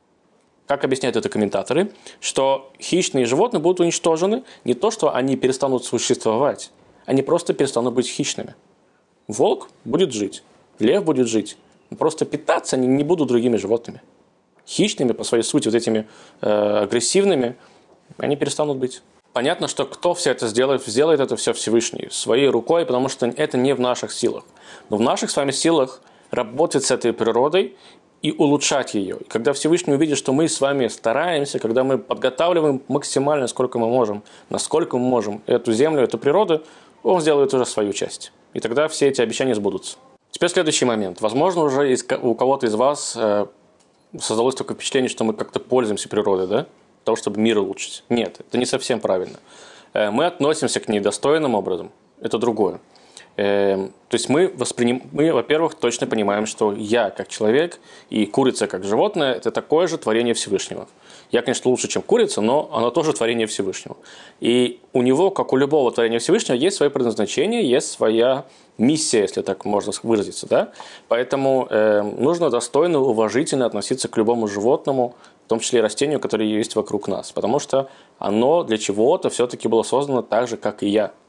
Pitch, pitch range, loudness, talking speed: 130 Hz, 115-150 Hz, -20 LUFS, 165 wpm